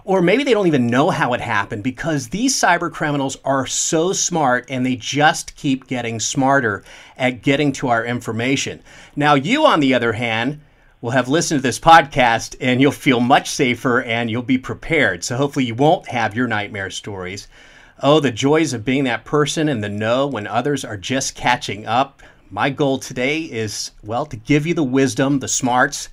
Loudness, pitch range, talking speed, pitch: -18 LUFS, 120-145 Hz, 195 wpm, 135 Hz